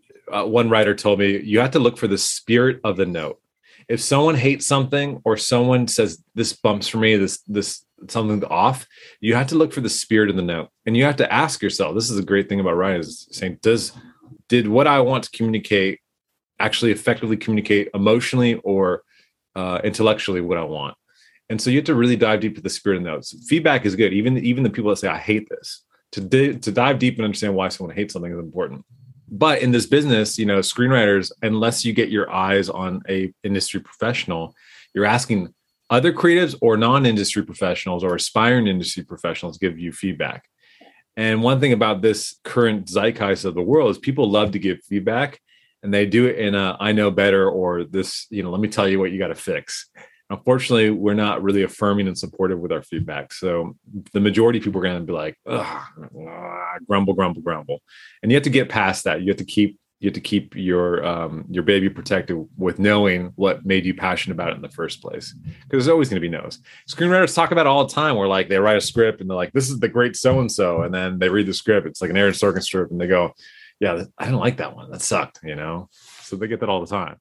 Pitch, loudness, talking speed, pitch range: 105 Hz, -20 LUFS, 230 wpm, 95-120 Hz